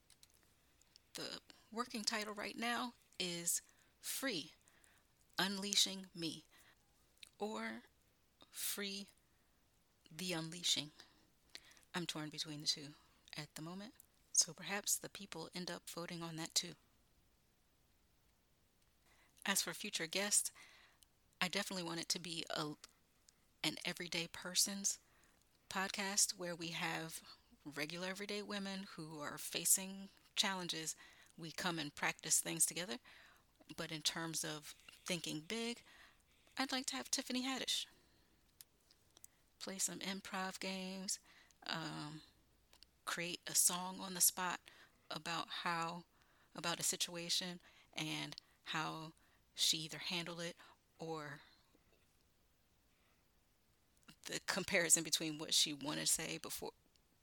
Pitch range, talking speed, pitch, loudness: 155-195 Hz, 110 wpm, 175 Hz, -40 LUFS